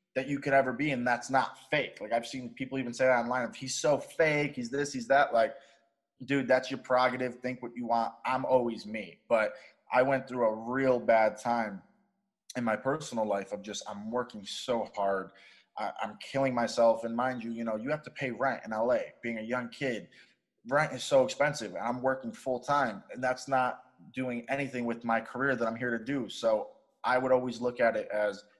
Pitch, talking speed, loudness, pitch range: 125 Hz, 220 wpm, -31 LUFS, 115-135 Hz